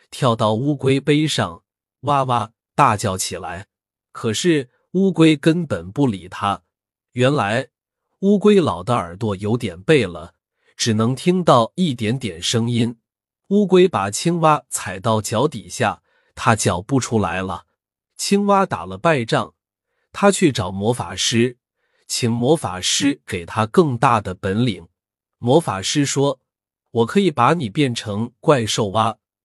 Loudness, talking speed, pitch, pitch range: -19 LUFS, 195 characters per minute, 120 Hz, 105-150 Hz